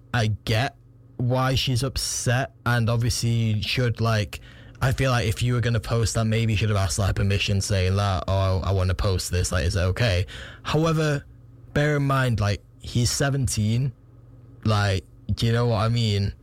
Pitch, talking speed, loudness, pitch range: 115 Hz, 195 wpm, -24 LUFS, 100-120 Hz